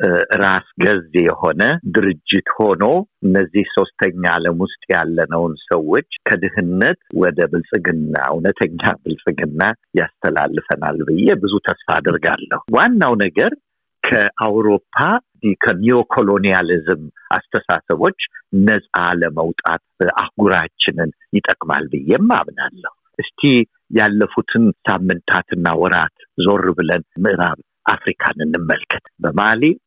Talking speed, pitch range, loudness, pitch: 85 wpm, 90-125 Hz, -16 LUFS, 100 Hz